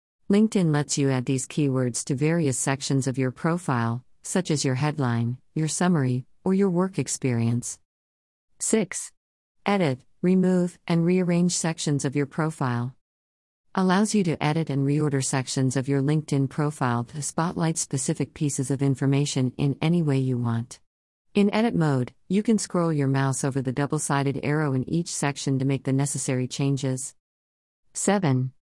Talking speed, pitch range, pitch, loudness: 155 wpm, 130-165 Hz, 140 Hz, -25 LUFS